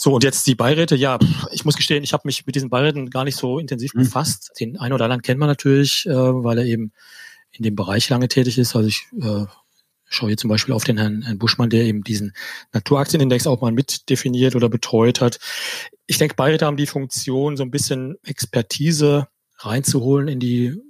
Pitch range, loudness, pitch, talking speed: 120-145 Hz, -19 LUFS, 130 Hz, 200 wpm